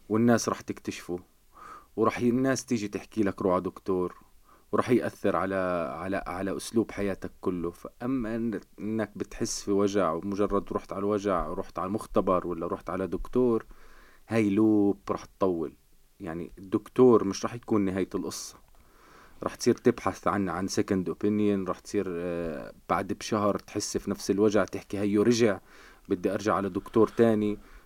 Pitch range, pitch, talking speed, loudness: 95-110 Hz, 100 Hz, 145 wpm, -28 LUFS